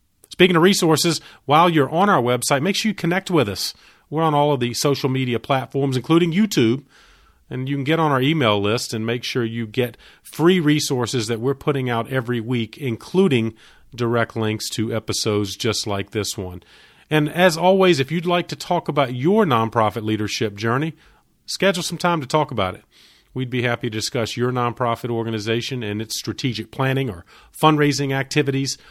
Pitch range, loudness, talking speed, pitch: 115-155 Hz, -20 LUFS, 185 wpm, 130 Hz